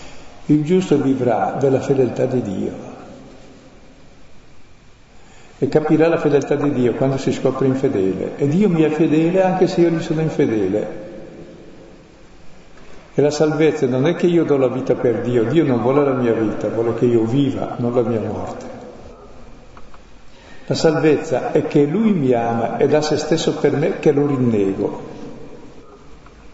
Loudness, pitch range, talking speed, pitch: -17 LUFS, 125-155 Hz, 160 wpm, 140 Hz